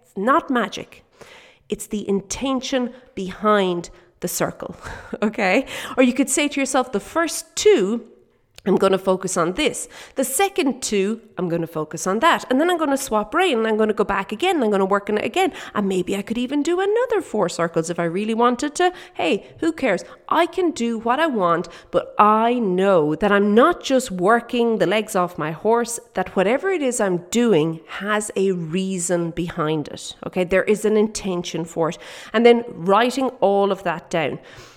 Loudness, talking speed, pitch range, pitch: -20 LUFS, 200 wpm, 185-260 Hz, 215 Hz